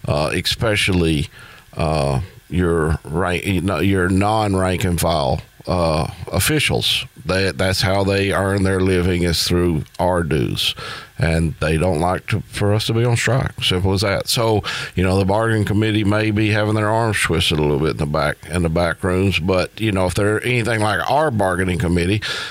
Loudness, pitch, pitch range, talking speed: -18 LUFS, 95 Hz, 85-105 Hz, 180 wpm